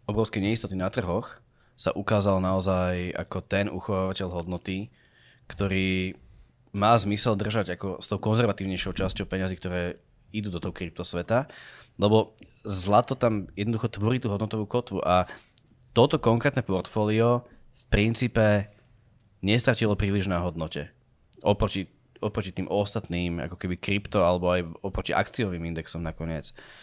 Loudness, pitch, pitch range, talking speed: -27 LUFS, 100 Hz, 90-110 Hz, 130 wpm